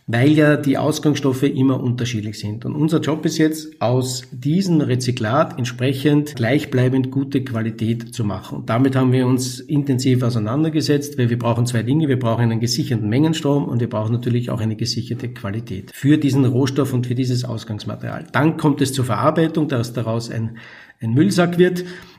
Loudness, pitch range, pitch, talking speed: -19 LUFS, 115-145 Hz, 130 Hz, 175 wpm